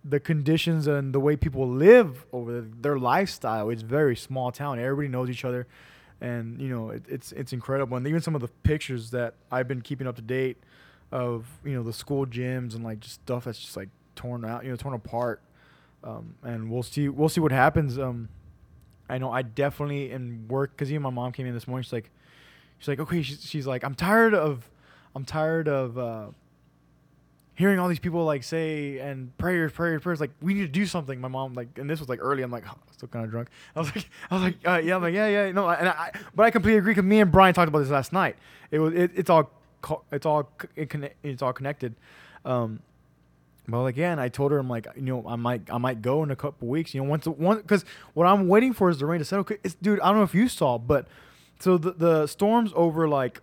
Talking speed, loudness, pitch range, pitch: 245 wpm, -26 LUFS, 125-165 Hz, 140 Hz